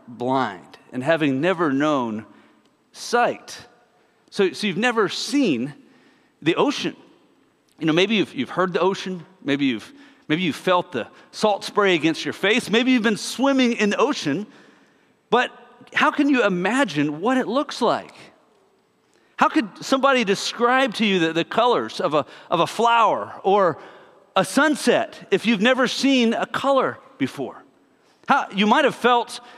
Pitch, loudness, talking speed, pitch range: 225 Hz, -21 LUFS, 165 wpm, 180-260 Hz